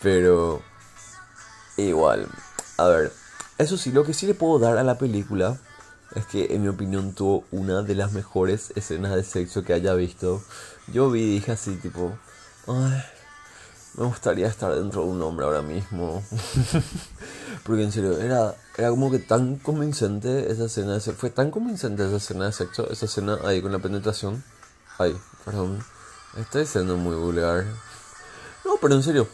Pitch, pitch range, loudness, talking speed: 105 Hz, 95-125 Hz, -24 LUFS, 170 wpm